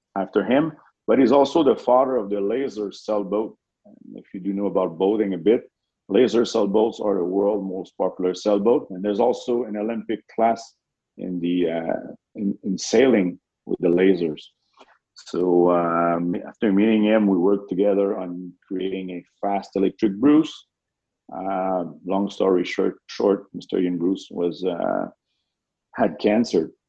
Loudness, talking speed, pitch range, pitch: -22 LUFS, 150 wpm, 90-105 Hz, 100 Hz